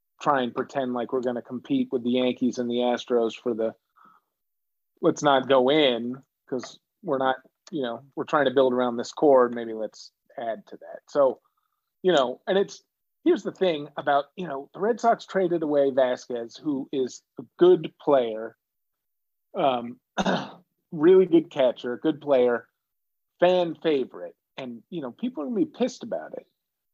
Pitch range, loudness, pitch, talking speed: 125-185 Hz, -25 LUFS, 140 Hz, 175 wpm